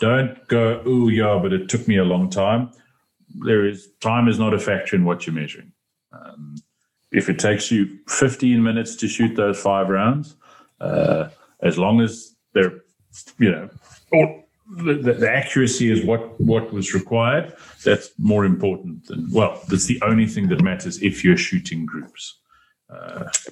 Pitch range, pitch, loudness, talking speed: 105-130 Hz, 115 Hz, -20 LUFS, 170 wpm